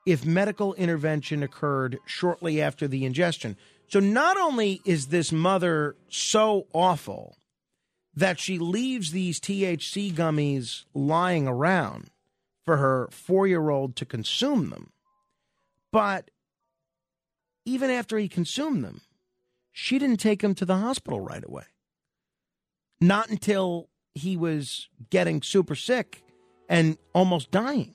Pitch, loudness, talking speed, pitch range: 175 Hz, -26 LUFS, 120 wpm, 150-200 Hz